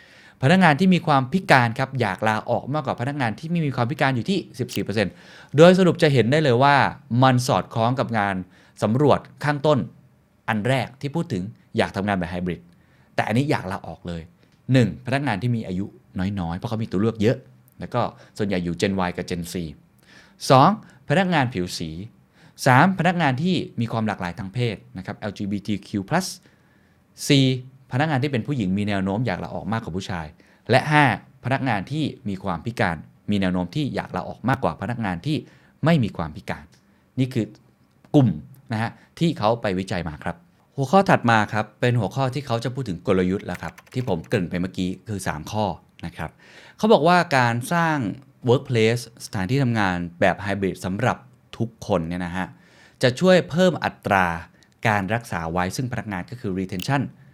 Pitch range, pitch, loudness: 90-135 Hz, 110 Hz, -22 LUFS